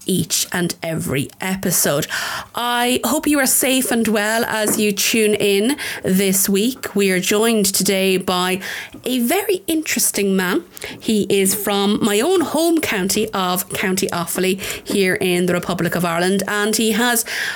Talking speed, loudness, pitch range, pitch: 155 wpm, -17 LUFS, 190-235 Hz, 205 Hz